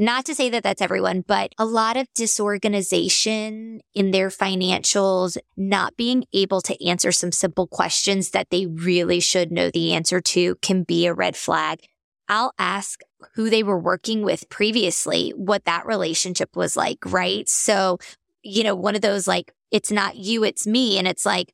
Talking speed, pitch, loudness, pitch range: 180 wpm, 195 Hz, -21 LUFS, 180-215 Hz